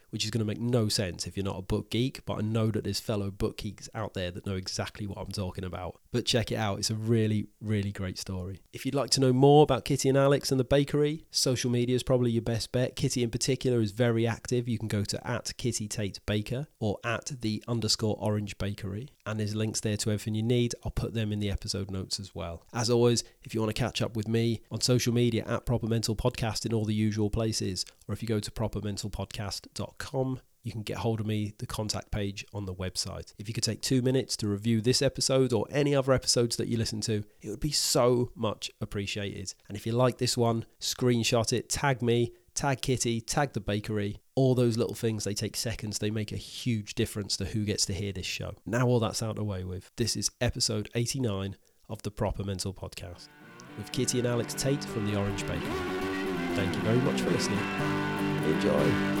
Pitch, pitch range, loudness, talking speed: 110 Hz, 100-120 Hz, -29 LUFS, 230 wpm